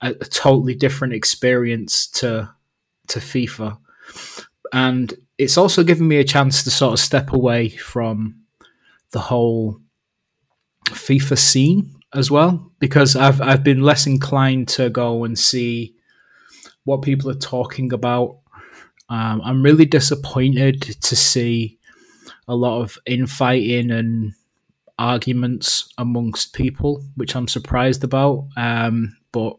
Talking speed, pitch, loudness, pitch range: 125 wpm, 125 Hz, -17 LUFS, 120-135 Hz